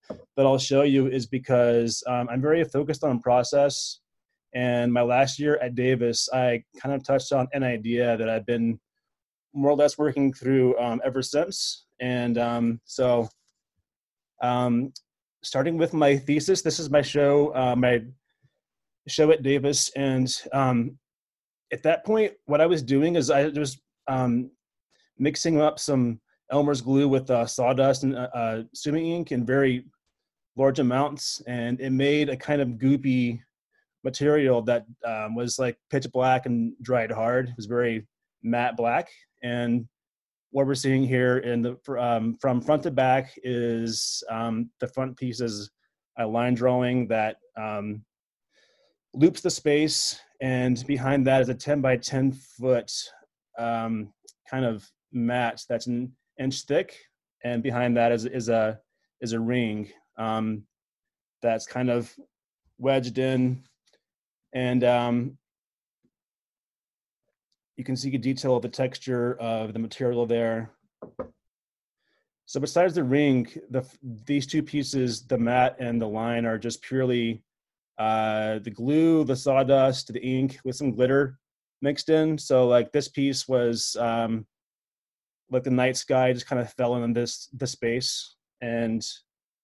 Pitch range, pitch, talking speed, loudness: 120-140 Hz, 125 Hz, 150 wpm, -25 LUFS